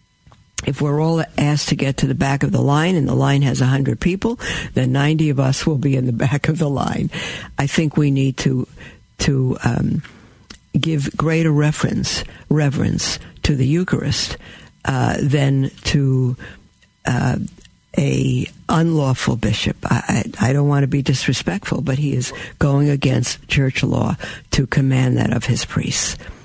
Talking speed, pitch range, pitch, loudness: 165 wpm, 130-150 Hz, 140 Hz, -19 LUFS